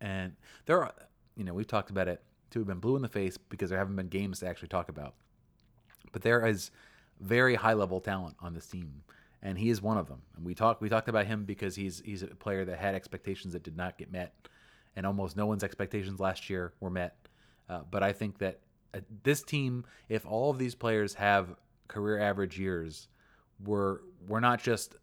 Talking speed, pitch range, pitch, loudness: 215 wpm, 95-110 Hz, 100 Hz, -33 LUFS